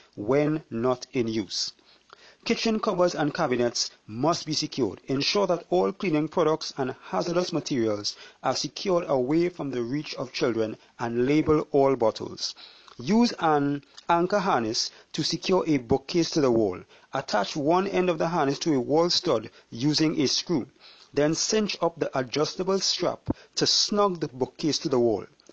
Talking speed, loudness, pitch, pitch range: 160 wpm, -26 LUFS, 150 Hz, 130-175 Hz